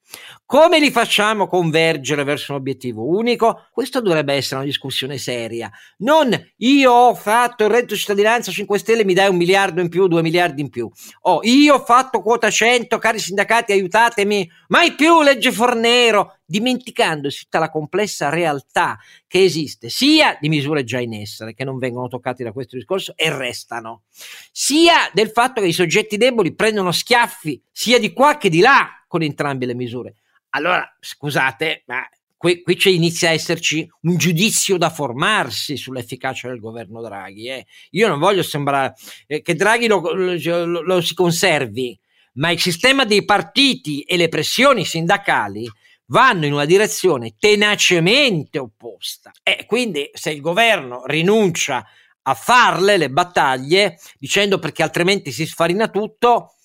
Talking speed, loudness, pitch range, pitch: 160 wpm, -16 LUFS, 145-215 Hz, 175 Hz